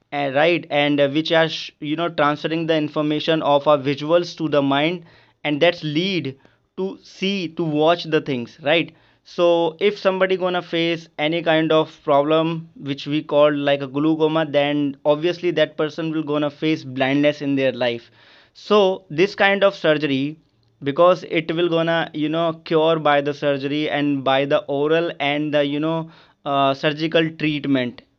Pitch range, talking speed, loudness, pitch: 145-165 Hz, 170 wpm, -20 LUFS, 155 Hz